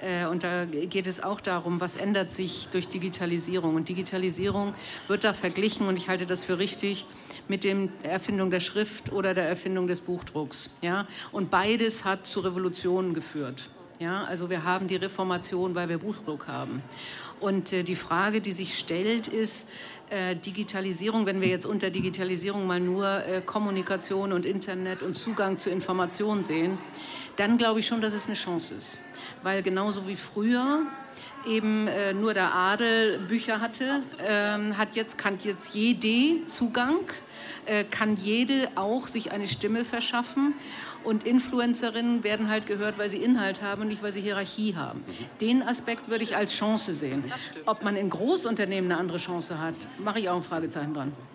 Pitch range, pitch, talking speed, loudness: 185-220 Hz, 195 Hz, 170 wpm, -28 LUFS